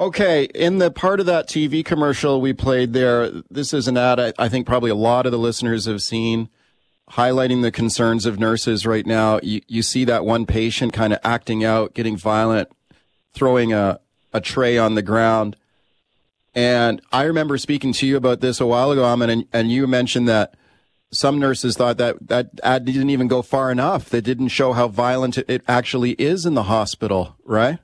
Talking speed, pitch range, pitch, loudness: 195 wpm, 115-130 Hz, 120 Hz, -19 LUFS